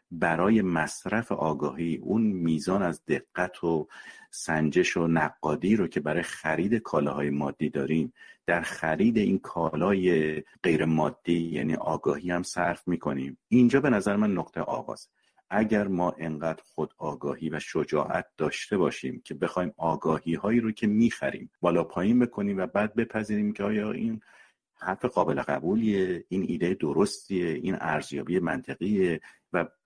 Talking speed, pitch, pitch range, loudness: 140 wpm, 85 Hz, 80-105 Hz, -28 LUFS